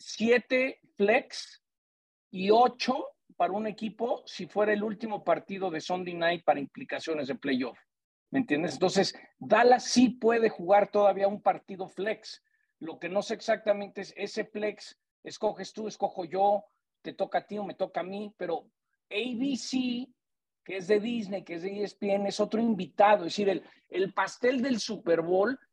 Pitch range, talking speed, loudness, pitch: 190-225 Hz, 170 wpm, -29 LUFS, 205 Hz